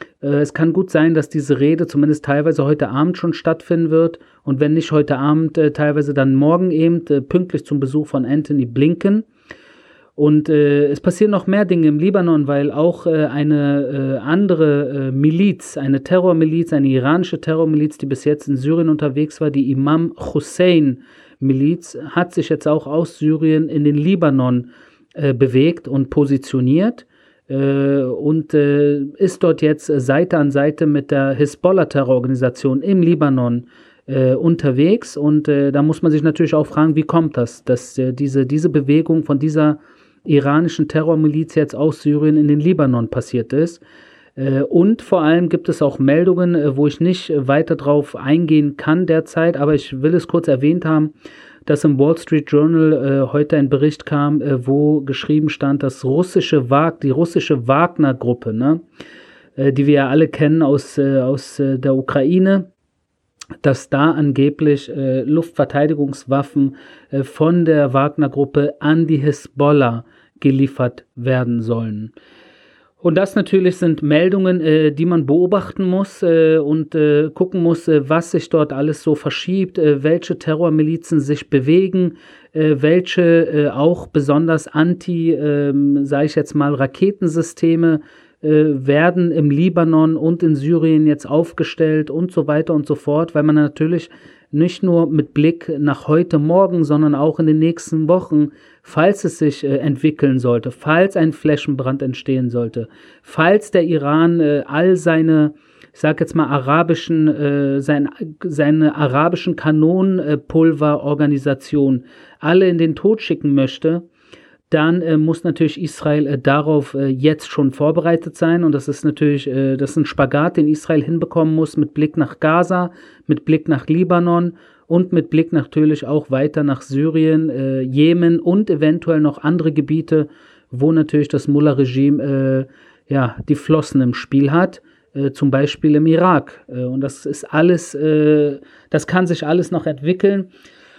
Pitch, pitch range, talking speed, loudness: 150 Hz, 145-165 Hz, 155 wpm, -16 LUFS